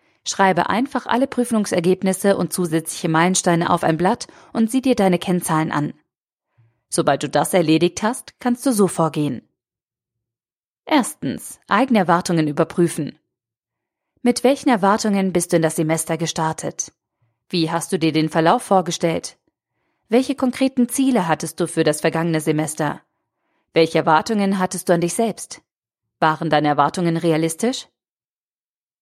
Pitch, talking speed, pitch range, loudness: 170 Hz, 135 wpm, 160-205 Hz, -19 LUFS